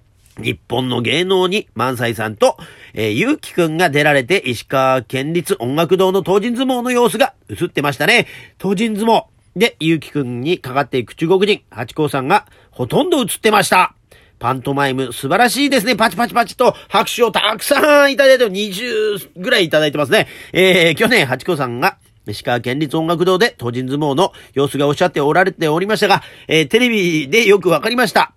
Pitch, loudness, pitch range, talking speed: 170 Hz, -15 LUFS, 130-215 Hz, 380 characters per minute